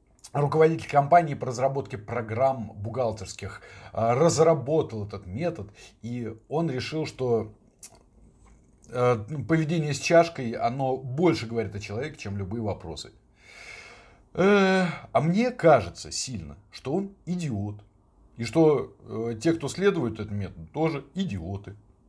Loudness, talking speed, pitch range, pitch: -26 LUFS, 110 wpm, 105-160 Hz, 125 Hz